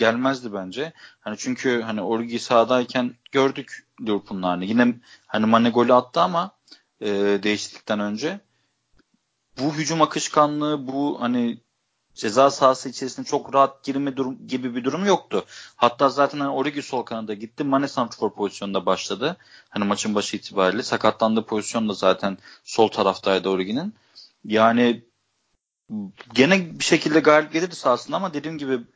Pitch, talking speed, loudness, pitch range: 120 Hz, 135 wpm, -22 LUFS, 110-135 Hz